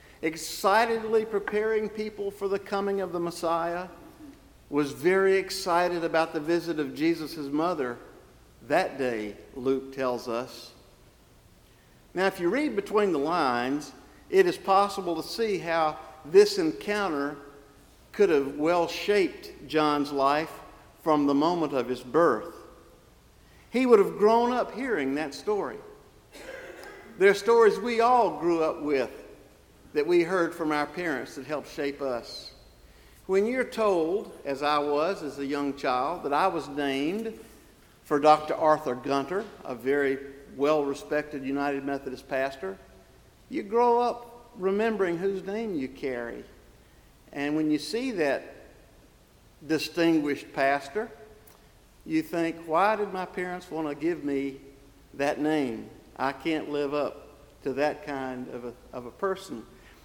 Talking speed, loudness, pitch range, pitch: 140 wpm, -27 LUFS, 140-200 Hz, 160 Hz